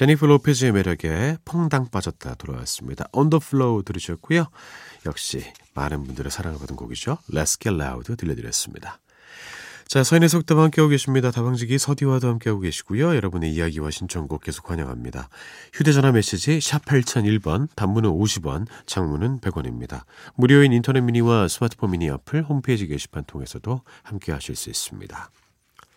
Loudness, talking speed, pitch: -22 LUFS, 380 characters per minute, 110 Hz